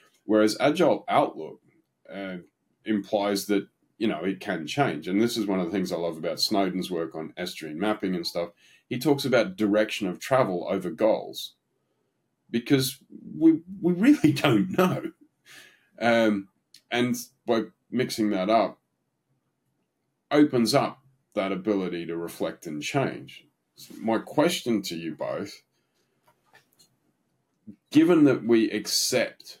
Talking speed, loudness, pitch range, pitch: 135 wpm, -25 LUFS, 95-135 Hz, 110 Hz